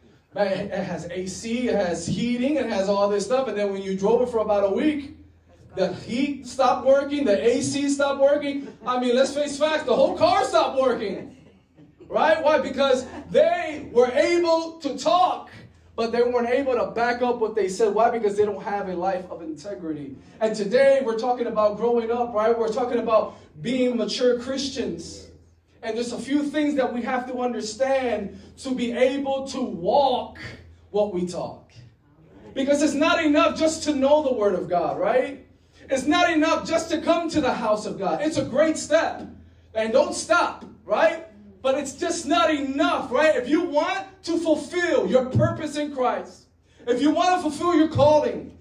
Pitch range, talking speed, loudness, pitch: 210-300 Hz, 190 wpm, -23 LUFS, 255 Hz